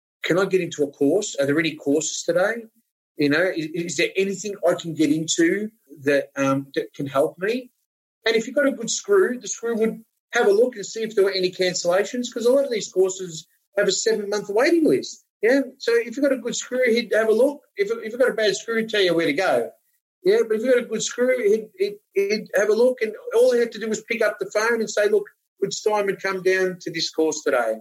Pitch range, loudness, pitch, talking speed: 175-250 Hz, -22 LUFS, 215 Hz, 255 wpm